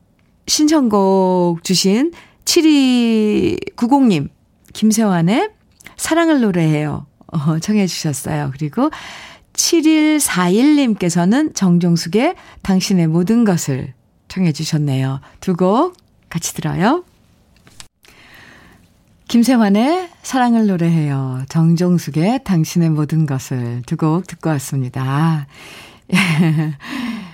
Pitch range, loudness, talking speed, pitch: 160-240 Hz, -16 LUFS, 190 characters per minute, 180 Hz